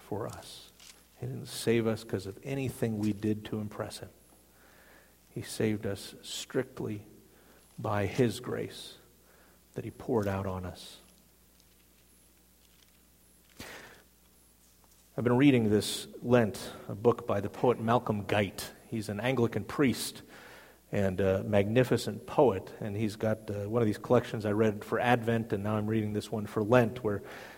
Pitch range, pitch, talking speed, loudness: 95-115 Hz, 105 Hz, 145 wpm, -31 LUFS